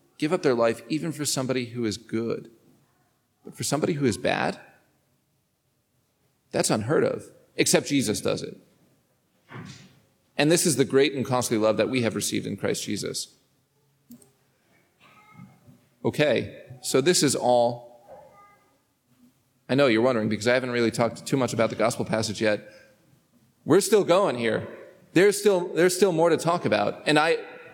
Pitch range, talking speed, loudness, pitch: 120-145 Hz, 160 wpm, -24 LUFS, 130 Hz